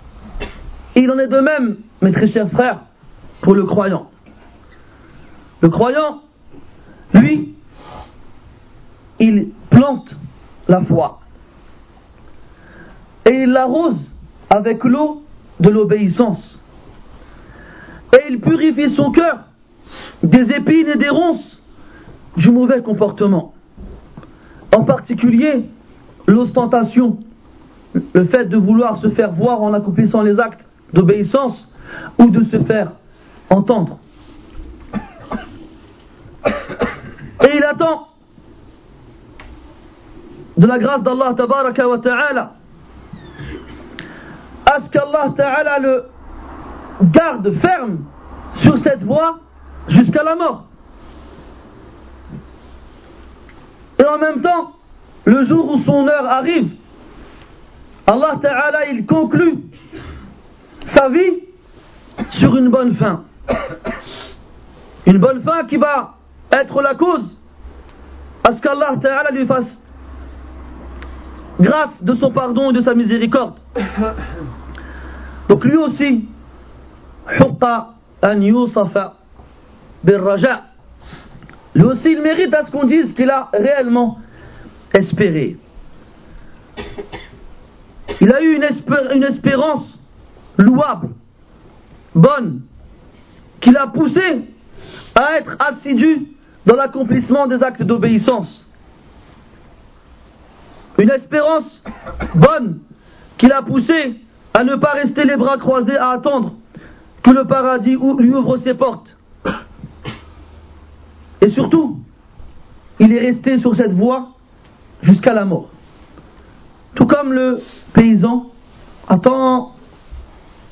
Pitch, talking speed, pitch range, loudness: 245 Hz, 100 wpm, 195-280 Hz, -14 LUFS